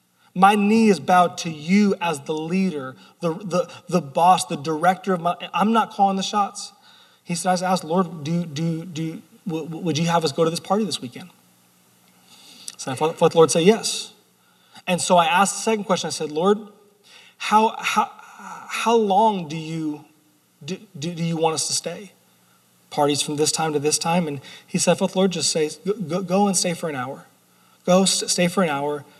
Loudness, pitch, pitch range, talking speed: -21 LUFS, 175 Hz, 155-200 Hz, 200 wpm